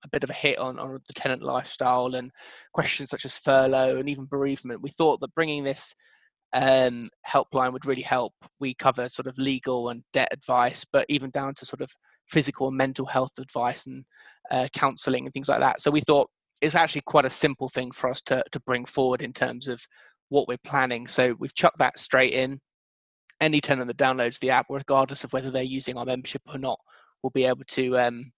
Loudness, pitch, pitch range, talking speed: -25 LUFS, 130 Hz, 125-140 Hz, 215 wpm